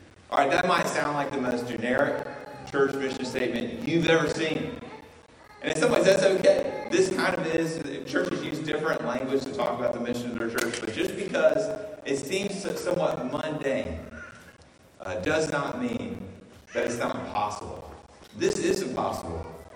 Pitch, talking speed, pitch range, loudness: 155 Hz, 165 wpm, 135-200 Hz, -27 LUFS